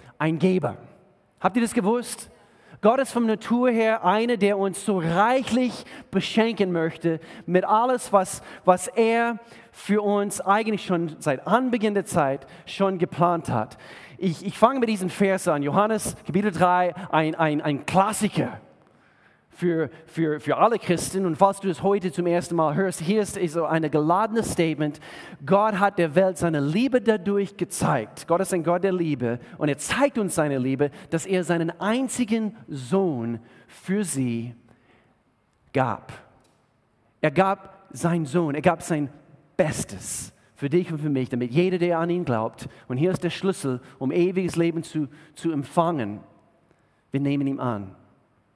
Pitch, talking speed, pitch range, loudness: 175 Hz, 160 wpm, 150-200 Hz, -24 LUFS